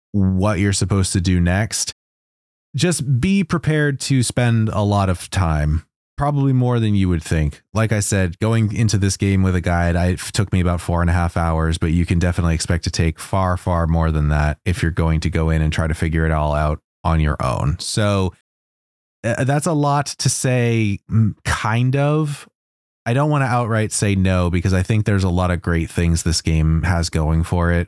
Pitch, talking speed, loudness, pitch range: 95 Hz, 215 wpm, -19 LUFS, 85-110 Hz